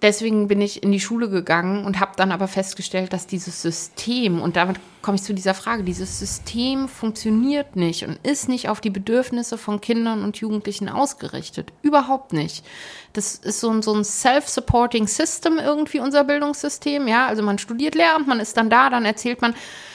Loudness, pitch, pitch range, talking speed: -21 LUFS, 220 Hz, 195-255 Hz, 180 wpm